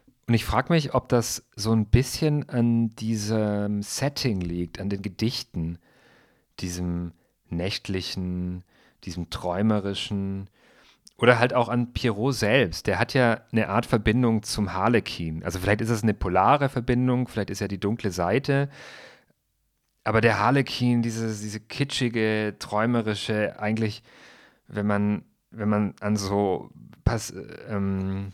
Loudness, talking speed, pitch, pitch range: -25 LUFS, 135 wpm, 105 Hz, 100-120 Hz